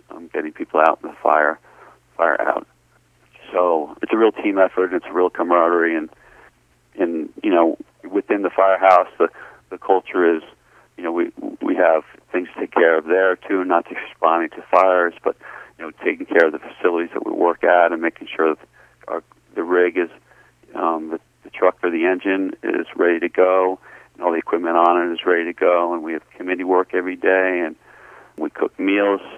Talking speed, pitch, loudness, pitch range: 200 wpm, 90 Hz, -19 LUFS, 85-95 Hz